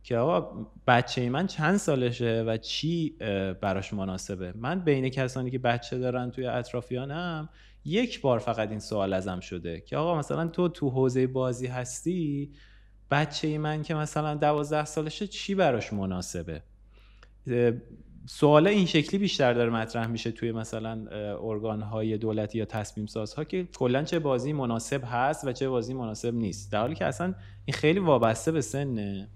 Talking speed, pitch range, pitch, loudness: 160 wpm, 110-150 Hz, 125 Hz, -28 LUFS